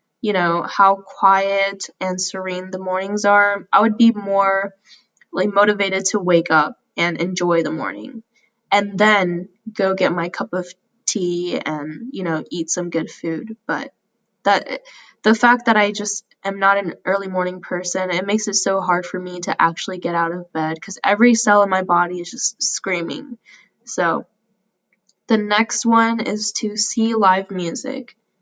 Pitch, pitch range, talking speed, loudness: 195 Hz, 180-215 Hz, 170 wpm, -19 LUFS